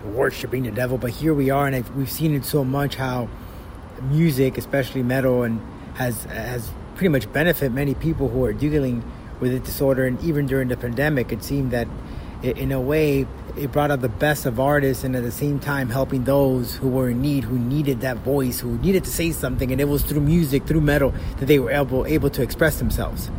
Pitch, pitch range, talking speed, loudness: 135 Hz, 125-145 Hz, 220 wpm, -22 LUFS